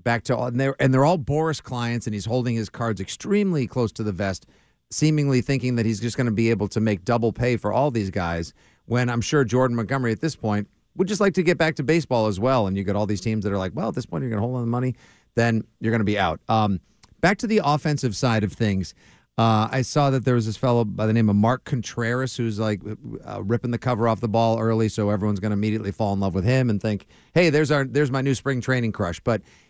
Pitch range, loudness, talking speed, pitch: 110-130 Hz, -23 LUFS, 275 wpm, 115 Hz